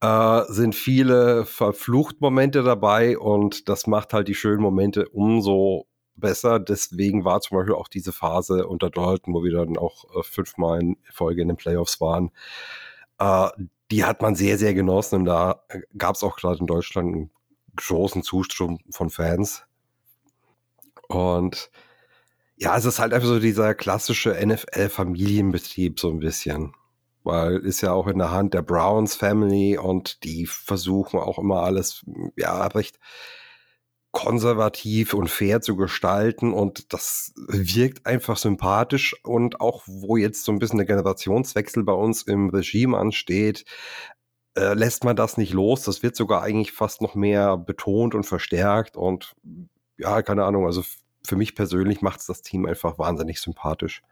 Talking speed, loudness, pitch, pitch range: 155 wpm, -22 LUFS, 100 Hz, 90-110 Hz